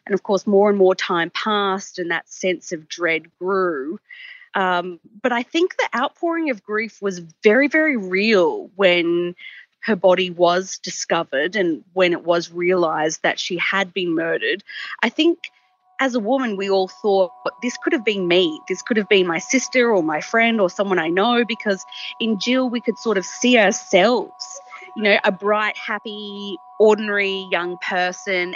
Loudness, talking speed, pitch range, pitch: -19 LUFS, 175 wpm, 180-240 Hz, 200 Hz